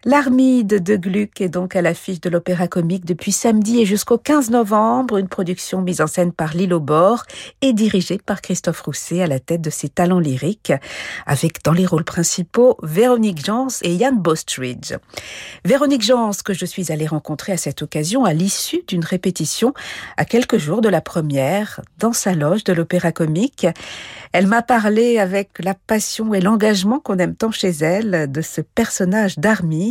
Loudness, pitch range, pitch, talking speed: -18 LUFS, 170-220 Hz, 190 Hz, 180 wpm